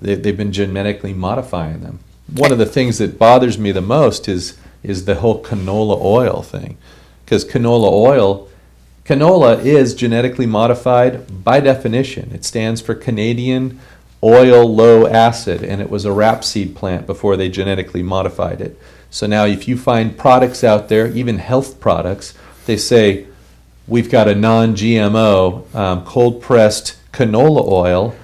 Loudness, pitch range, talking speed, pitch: -13 LUFS, 95-120 Hz, 155 wpm, 110 Hz